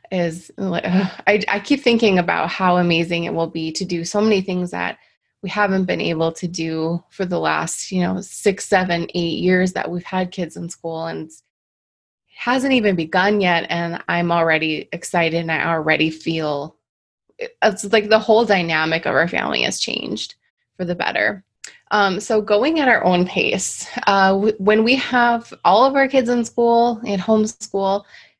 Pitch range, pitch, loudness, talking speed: 170-215 Hz, 185 Hz, -18 LUFS, 185 wpm